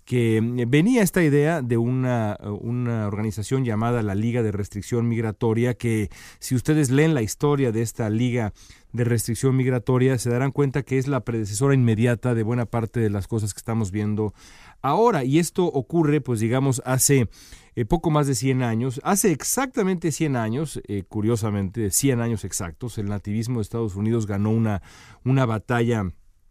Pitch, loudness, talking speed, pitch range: 120 Hz, -23 LUFS, 170 wpm, 110-135 Hz